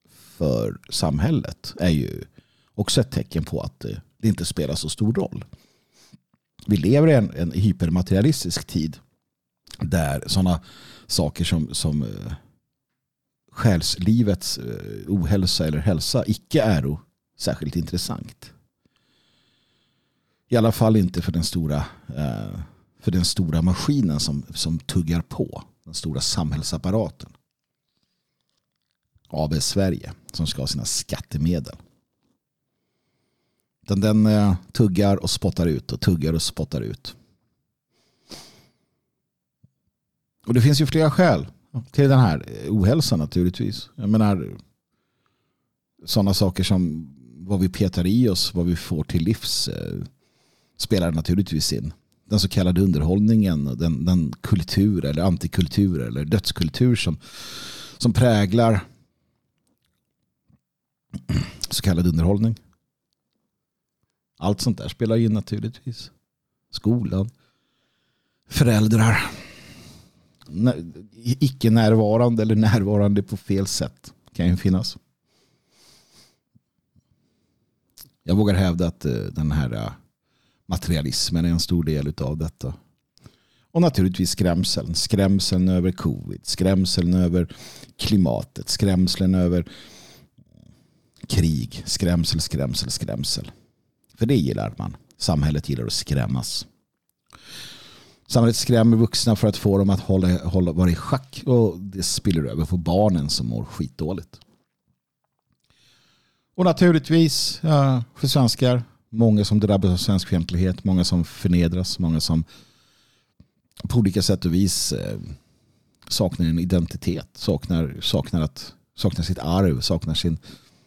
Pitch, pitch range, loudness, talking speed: 95 Hz, 85-110 Hz, -22 LUFS, 115 wpm